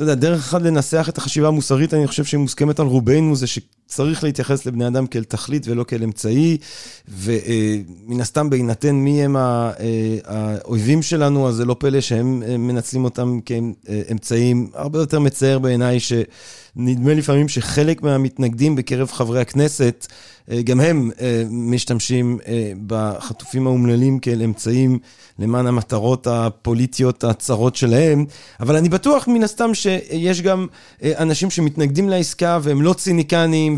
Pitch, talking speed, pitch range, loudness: 130 Hz, 150 wpm, 120-150 Hz, -18 LUFS